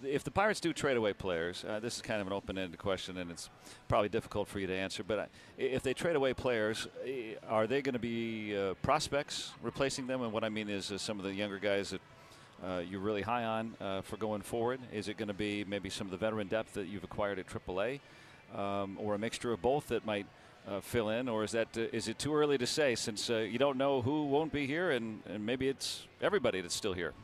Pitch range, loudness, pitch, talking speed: 100-130 Hz, -35 LUFS, 110 Hz, 255 wpm